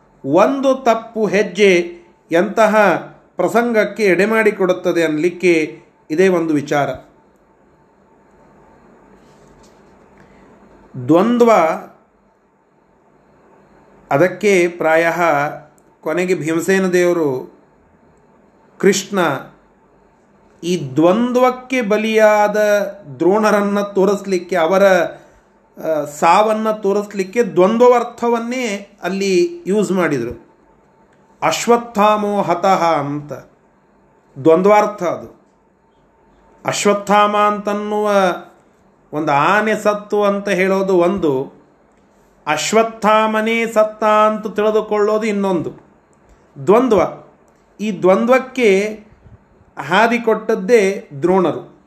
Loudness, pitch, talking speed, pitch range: -15 LUFS, 200 Hz, 65 wpm, 175-215 Hz